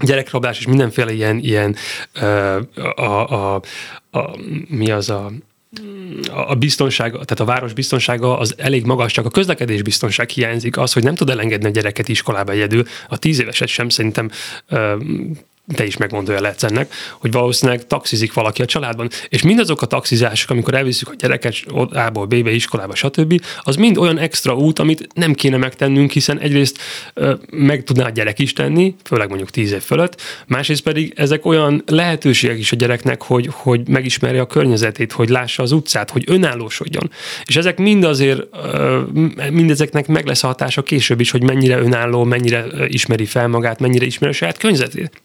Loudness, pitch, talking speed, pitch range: -16 LUFS, 125 Hz, 180 wpm, 115-150 Hz